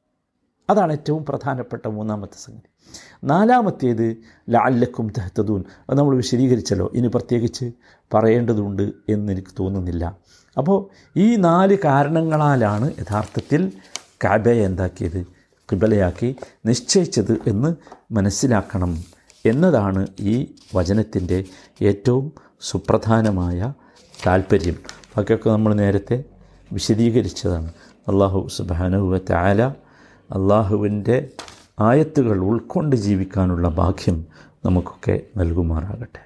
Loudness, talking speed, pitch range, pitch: -20 LUFS, 80 wpm, 95-125 Hz, 110 Hz